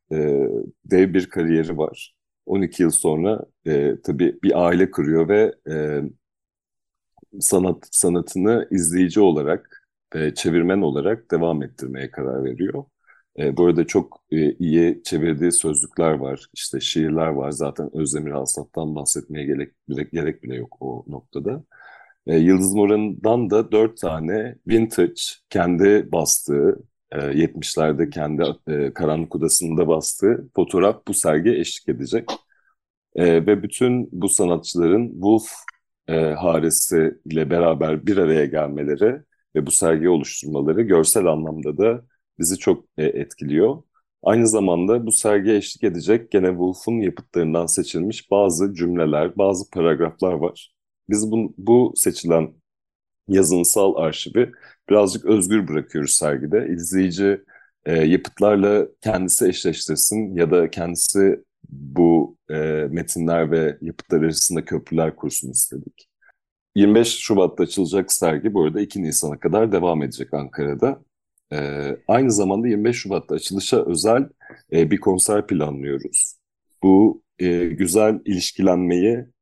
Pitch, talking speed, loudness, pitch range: 85 Hz, 120 wpm, -20 LUFS, 80-100 Hz